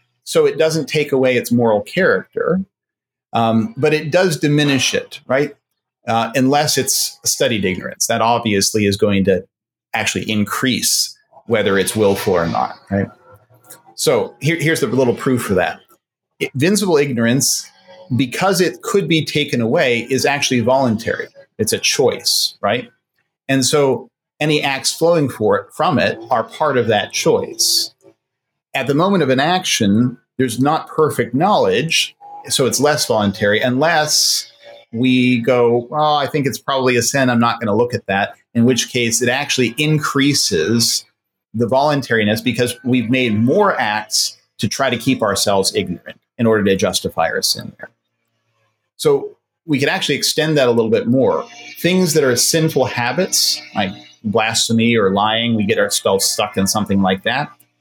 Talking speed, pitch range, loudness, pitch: 160 wpm, 115-155 Hz, -16 LUFS, 130 Hz